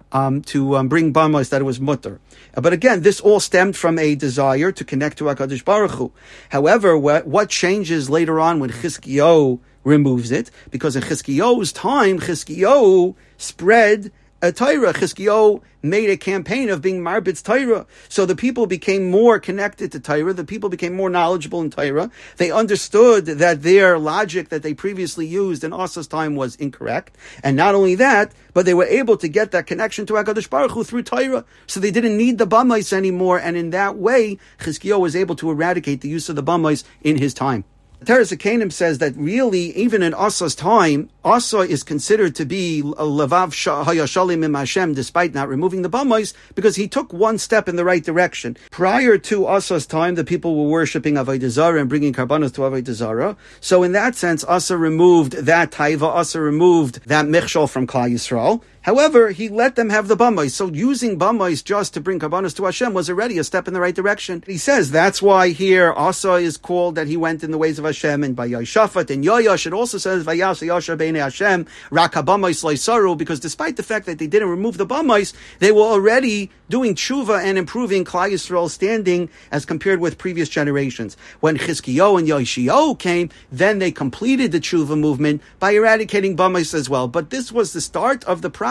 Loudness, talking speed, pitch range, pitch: -17 LUFS, 185 wpm, 155-200 Hz, 175 Hz